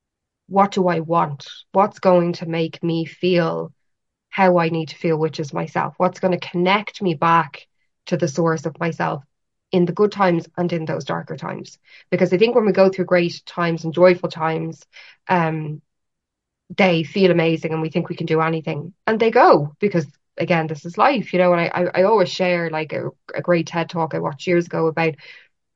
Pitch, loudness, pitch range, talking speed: 175 Hz, -19 LUFS, 160-185 Hz, 205 wpm